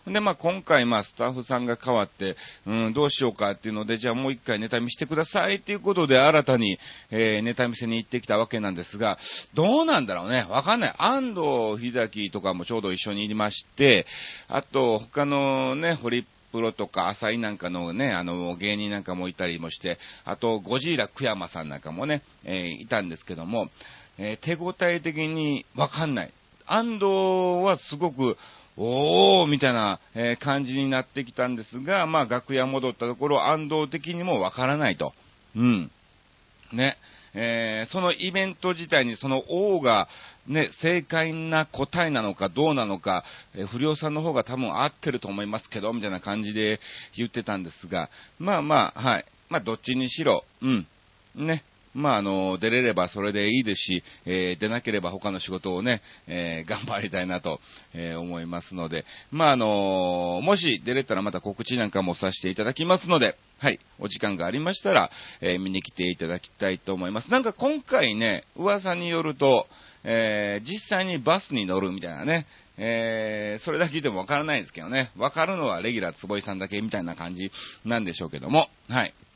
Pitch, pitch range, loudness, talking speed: 115 Hz, 100-150 Hz, -26 LUFS, 375 characters per minute